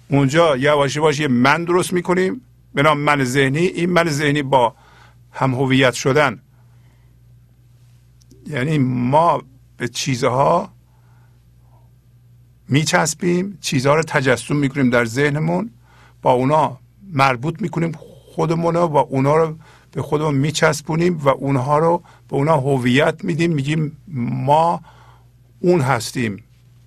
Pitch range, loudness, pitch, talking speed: 125-155 Hz, -18 LUFS, 140 Hz, 115 wpm